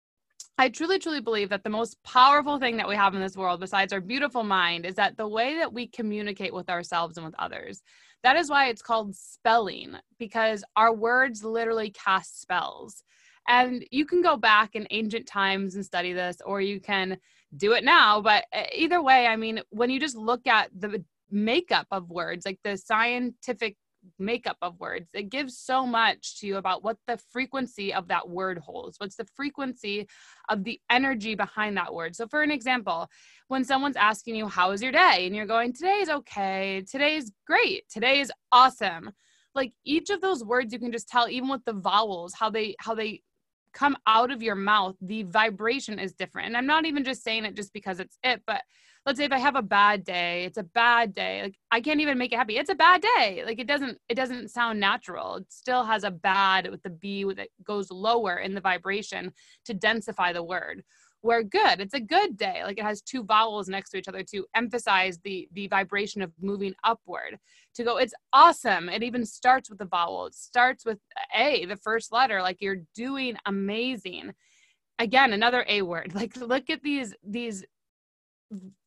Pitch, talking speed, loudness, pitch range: 225 Hz, 200 wpm, -25 LUFS, 195-255 Hz